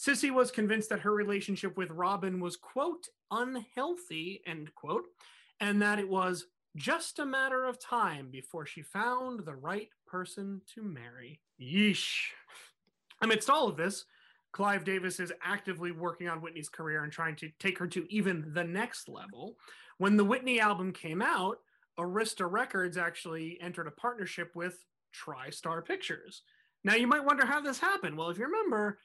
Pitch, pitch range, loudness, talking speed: 195 Hz, 175-235 Hz, -33 LUFS, 165 wpm